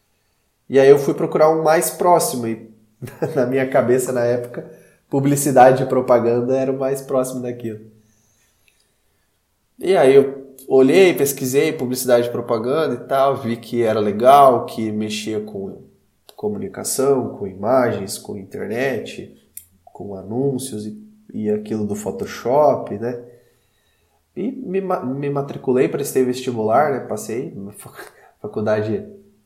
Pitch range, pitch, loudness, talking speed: 110-140 Hz, 125 Hz, -18 LUFS, 130 wpm